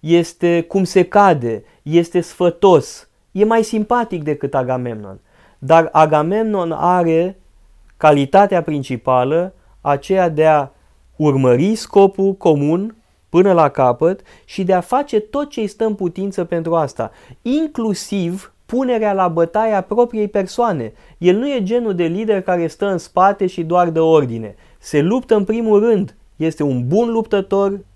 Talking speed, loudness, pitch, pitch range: 140 wpm, -16 LUFS, 180 Hz, 155-205 Hz